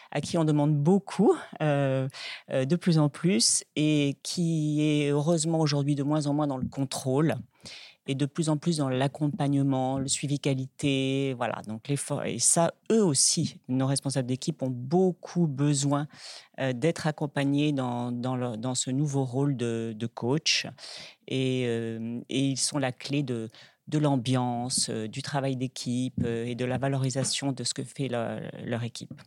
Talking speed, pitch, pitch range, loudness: 175 wpm, 140 Hz, 130-150 Hz, -27 LUFS